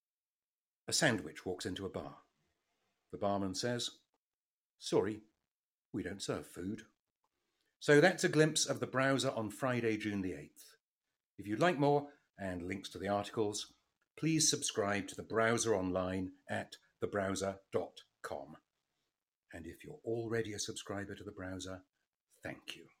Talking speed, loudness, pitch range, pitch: 140 wpm, -36 LUFS, 95-125 Hz, 105 Hz